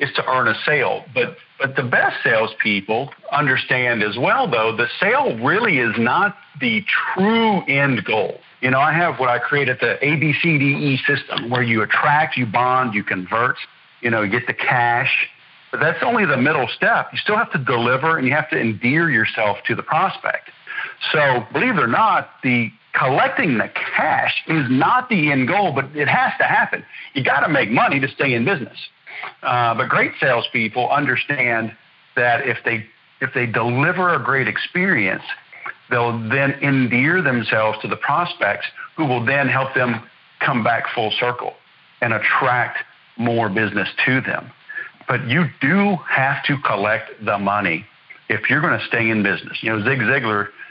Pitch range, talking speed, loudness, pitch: 115-150 Hz, 180 wpm, -18 LUFS, 130 Hz